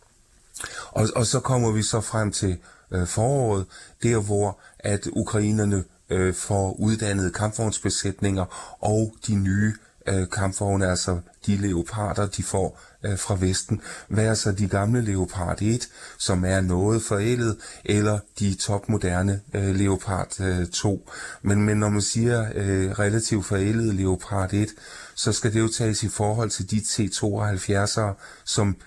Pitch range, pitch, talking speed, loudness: 95-110 Hz, 100 Hz, 145 wpm, -24 LUFS